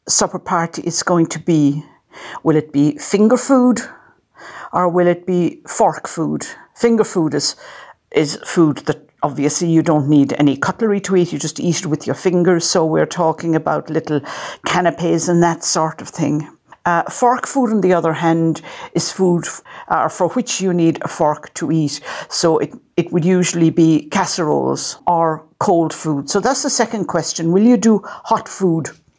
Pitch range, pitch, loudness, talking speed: 155-185 Hz, 170 Hz, -17 LUFS, 180 wpm